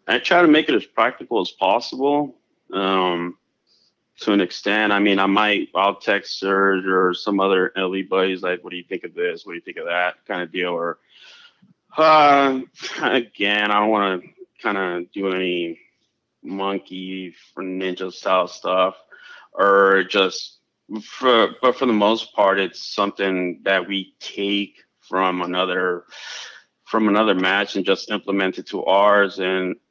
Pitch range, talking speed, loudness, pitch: 95-105 Hz, 165 wpm, -20 LUFS, 95 Hz